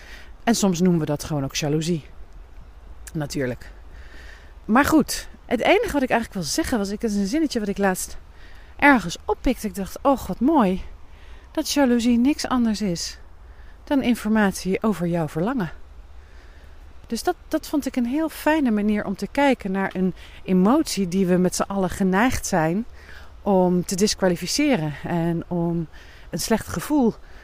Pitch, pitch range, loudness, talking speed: 195 Hz, 160-245 Hz, -22 LUFS, 160 wpm